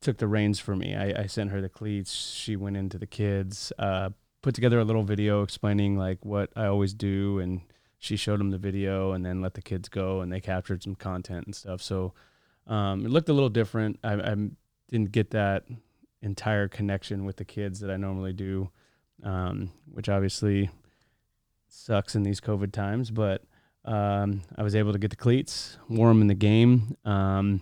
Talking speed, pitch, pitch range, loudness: 195 wpm, 100 Hz, 95-110 Hz, -28 LUFS